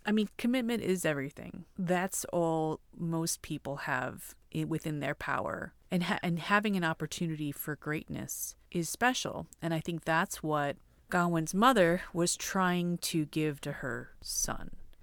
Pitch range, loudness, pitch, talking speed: 155-185 Hz, -32 LUFS, 170 Hz, 150 wpm